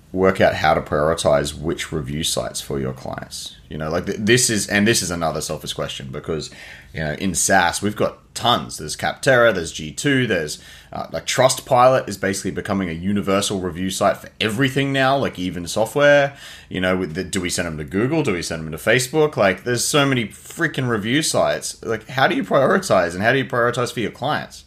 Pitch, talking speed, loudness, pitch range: 95 Hz, 215 wpm, -19 LUFS, 85-120 Hz